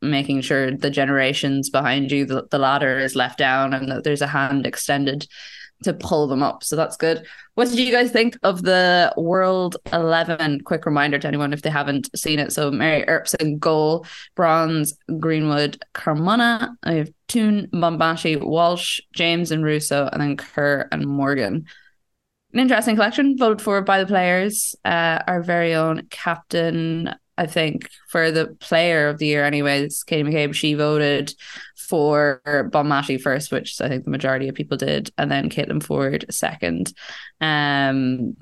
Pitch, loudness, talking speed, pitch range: 155 Hz, -20 LUFS, 165 wpm, 140-170 Hz